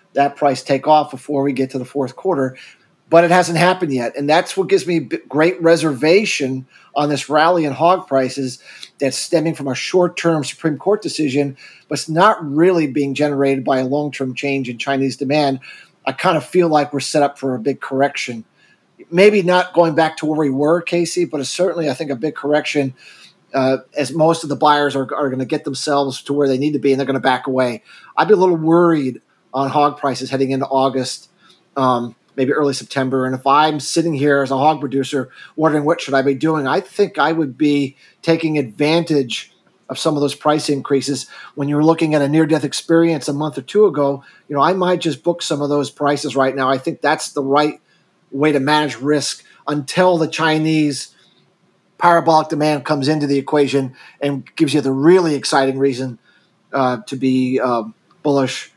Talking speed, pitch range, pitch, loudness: 205 wpm, 135-160 Hz, 145 Hz, -17 LUFS